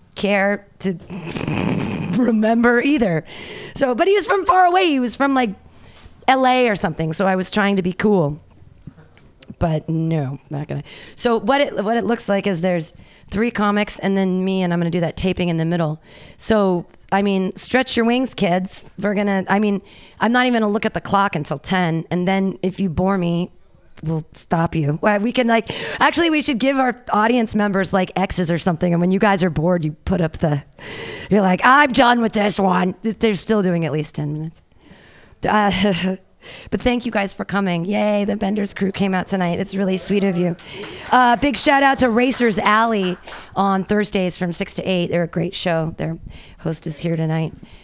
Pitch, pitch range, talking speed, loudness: 195 Hz, 175-220 Hz, 205 wpm, -19 LUFS